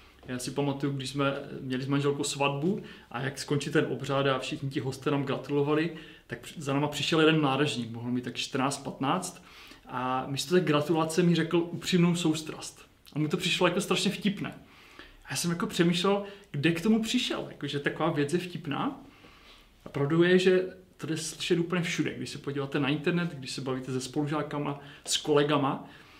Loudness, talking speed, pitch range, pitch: -29 LUFS, 185 wpm, 140-175 Hz, 150 Hz